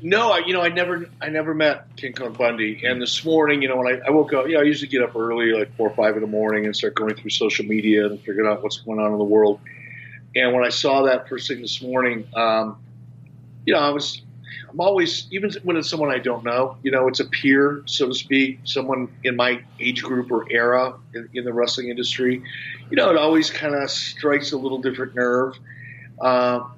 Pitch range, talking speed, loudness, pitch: 120-140 Hz, 240 wpm, -21 LUFS, 125 Hz